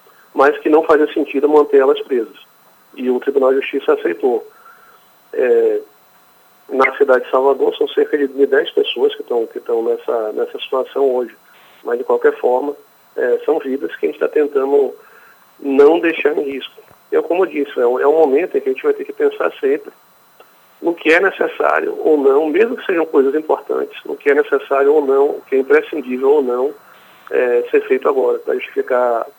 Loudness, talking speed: -16 LUFS, 195 wpm